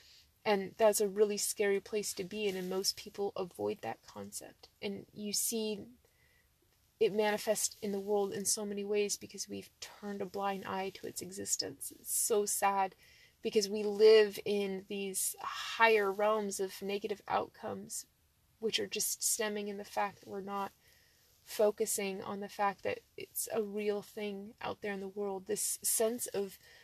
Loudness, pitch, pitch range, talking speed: -34 LUFS, 205 Hz, 200-215 Hz, 170 wpm